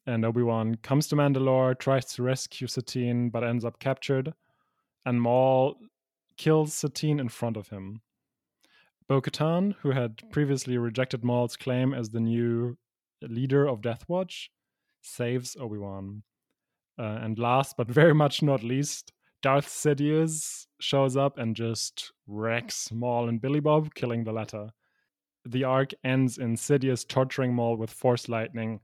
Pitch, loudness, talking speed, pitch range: 125 Hz, -27 LUFS, 145 wpm, 115-140 Hz